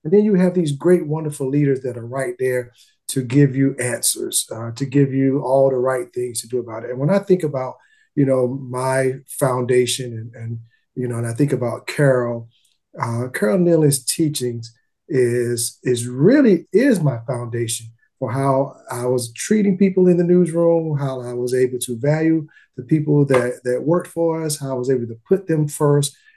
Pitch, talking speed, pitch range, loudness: 135 Hz, 195 wpm, 125-155 Hz, -19 LUFS